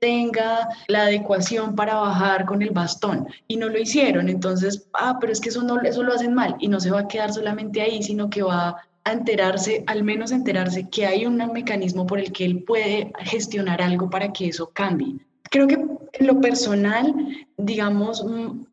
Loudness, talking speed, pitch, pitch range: -22 LUFS, 190 wpm, 215 Hz, 195-235 Hz